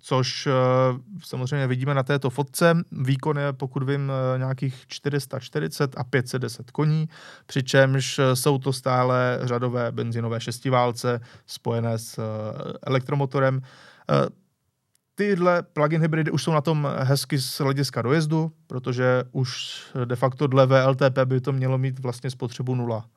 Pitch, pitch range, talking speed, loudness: 135 Hz, 125-145 Hz, 125 wpm, -24 LUFS